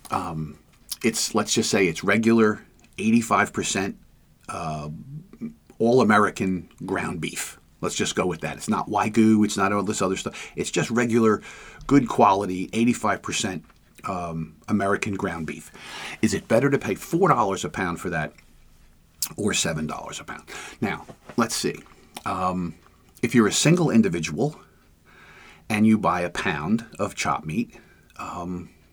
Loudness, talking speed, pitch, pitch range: -23 LUFS, 145 wpm, 95 Hz, 85-115 Hz